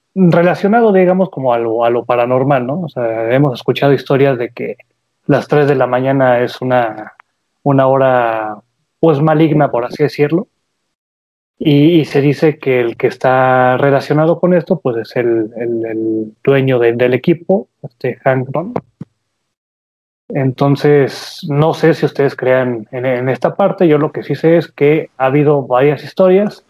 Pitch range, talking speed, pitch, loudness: 125-155 Hz, 165 wpm, 140 Hz, -13 LUFS